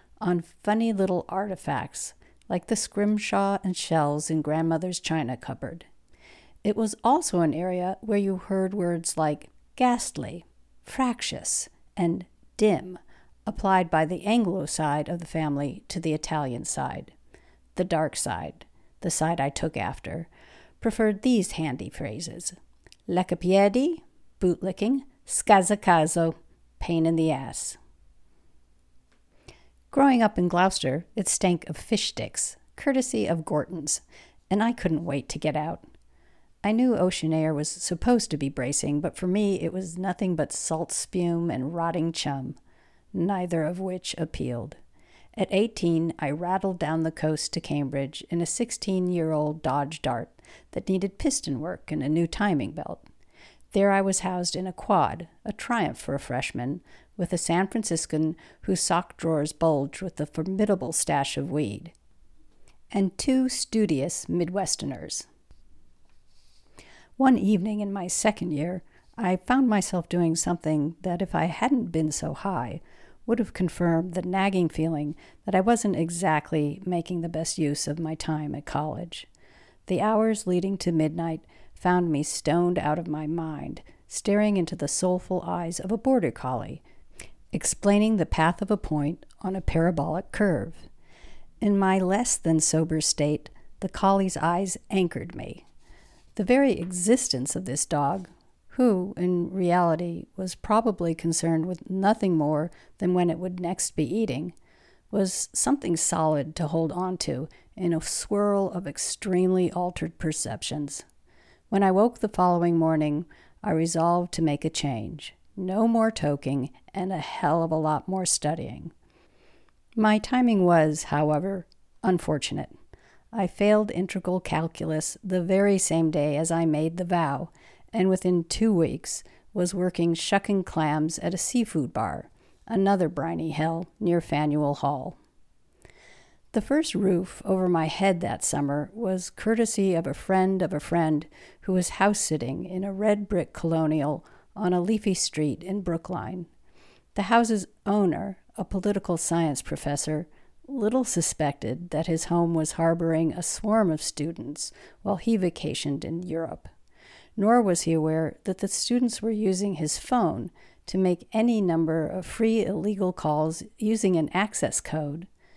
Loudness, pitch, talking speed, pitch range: -26 LUFS, 175 Hz, 145 wpm, 155-195 Hz